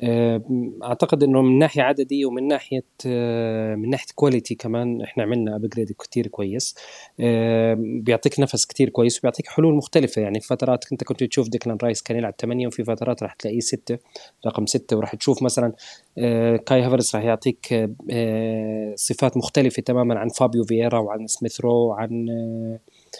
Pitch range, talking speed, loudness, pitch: 115-130 Hz, 145 wpm, -22 LUFS, 120 Hz